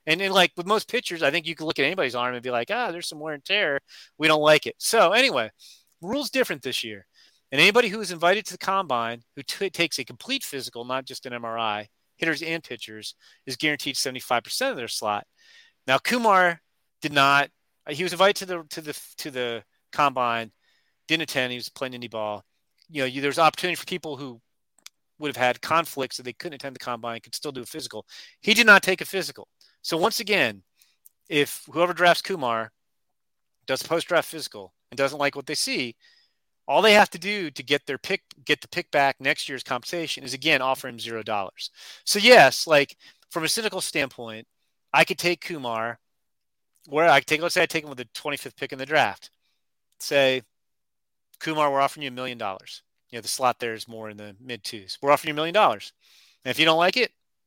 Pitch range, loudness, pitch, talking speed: 125-175 Hz, -23 LUFS, 145 Hz, 215 wpm